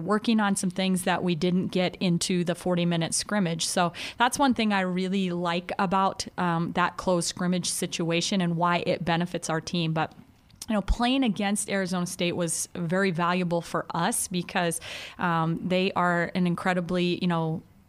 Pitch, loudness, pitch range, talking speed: 180 Hz, -26 LUFS, 170-190 Hz, 175 wpm